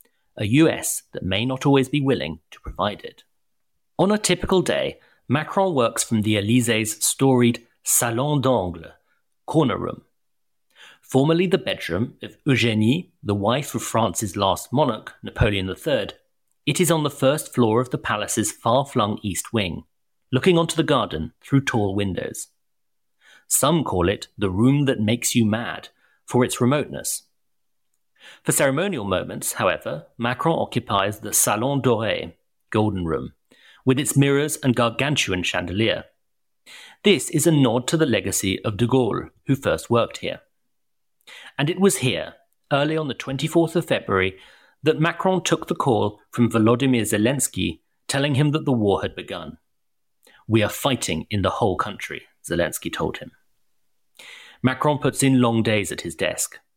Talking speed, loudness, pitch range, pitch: 150 wpm, -22 LUFS, 110-145 Hz, 125 Hz